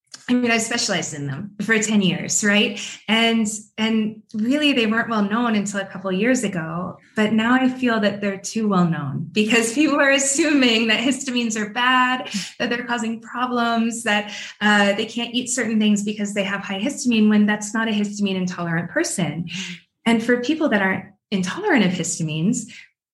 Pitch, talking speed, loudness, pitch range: 215 Hz, 185 wpm, -20 LUFS, 200-240 Hz